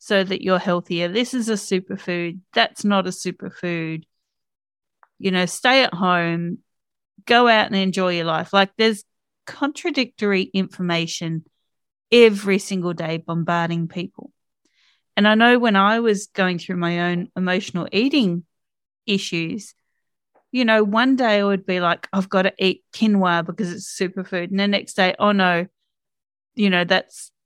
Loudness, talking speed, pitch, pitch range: -20 LUFS, 155 wpm, 190 Hz, 175-215 Hz